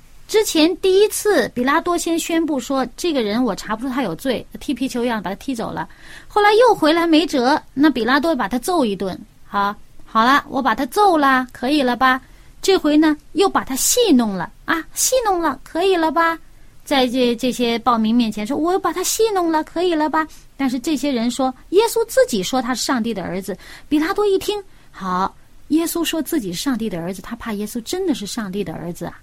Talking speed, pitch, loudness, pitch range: 300 characters per minute, 275 Hz, -18 LUFS, 240-335 Hz